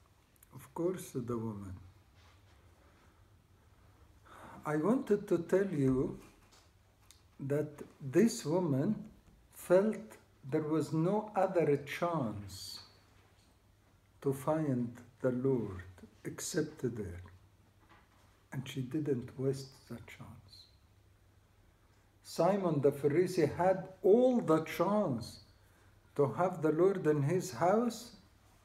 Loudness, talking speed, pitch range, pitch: -33 LUFS, 90 wpm, 100-160 Hz, 120 Hz